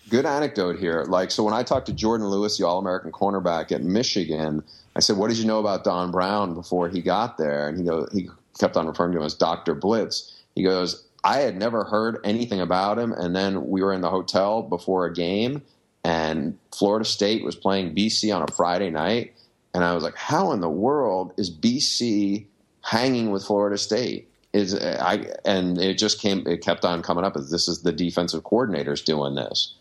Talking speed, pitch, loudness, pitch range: 205 wpm, 95 Hz, -24 LUFS, 85-105 Hz